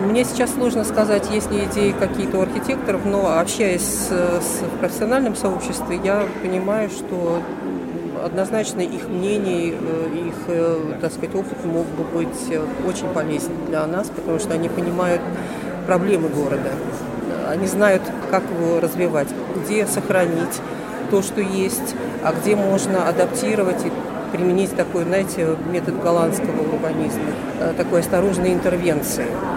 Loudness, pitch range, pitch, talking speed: -21 LUFS, 170-210 Hz, 190 Hz, 130 wpm